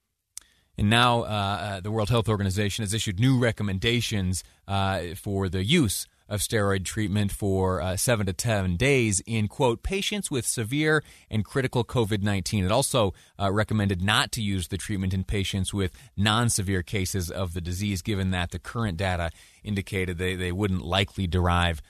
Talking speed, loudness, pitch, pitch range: 170 wpm, -26 LUFS, 100 Hz, 95-110 Hz